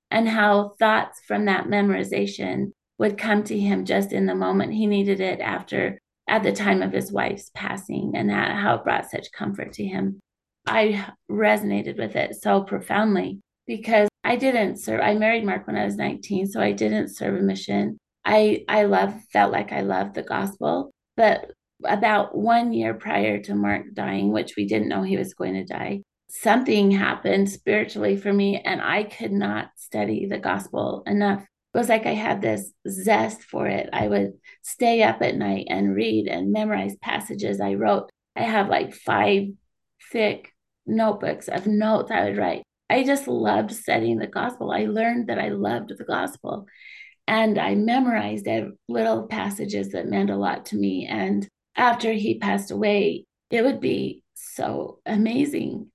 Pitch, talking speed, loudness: 195 Hz, 175 wpm, -23 LUFS